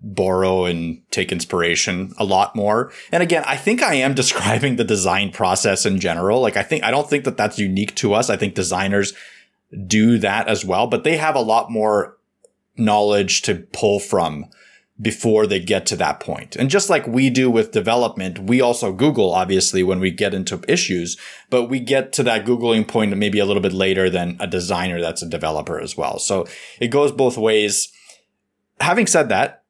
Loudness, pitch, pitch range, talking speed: -18 LUFS, 105 Hz, 95-130 Hz, 195 wpm